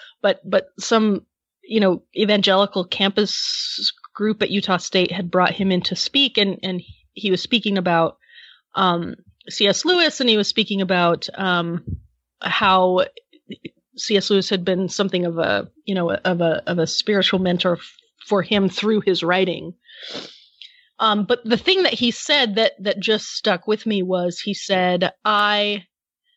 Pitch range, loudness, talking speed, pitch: 185-220 Hz, -19 LUFS, 160 wpm, 200 Hz